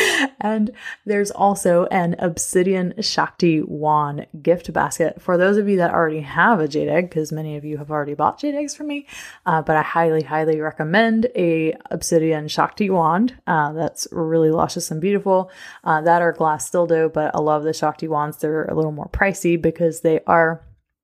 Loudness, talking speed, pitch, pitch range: -19 LUFS, 190 wpm, 165 Hz, 155-190 Hz